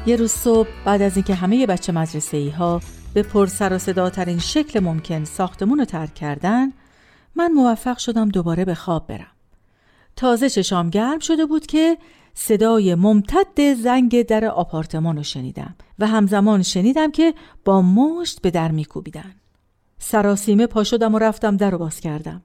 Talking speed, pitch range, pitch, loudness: 160 wpm, 165-235 Hz, 200 Hz, -19 LUFS